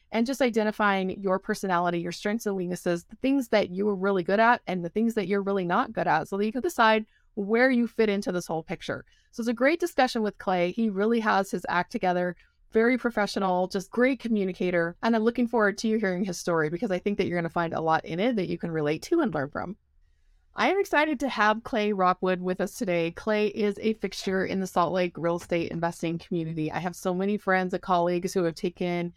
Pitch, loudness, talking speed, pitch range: 195 Hz, -27 LUFS, 240 wpm, 175-220 Hz